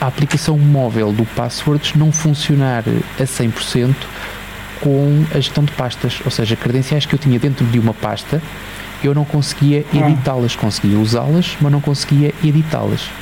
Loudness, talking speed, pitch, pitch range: -16 LUFS, 155 wpm, 140 Hz, 120-150 Hz